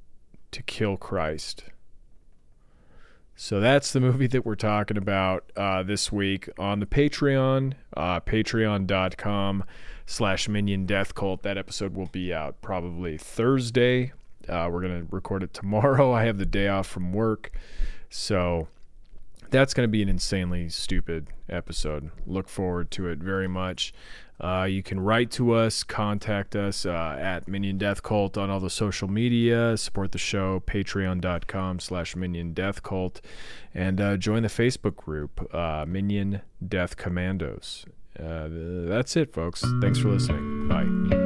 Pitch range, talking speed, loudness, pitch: 90-110 Hz, 145 wpm, -27 LUFS, 95 Hz